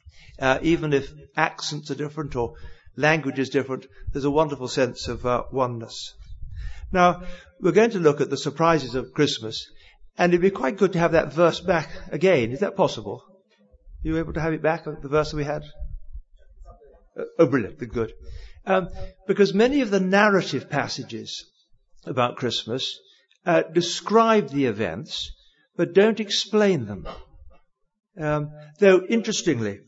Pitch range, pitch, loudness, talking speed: 125-185 Hz, 150 Hz, -23 LUFS, 155 wpm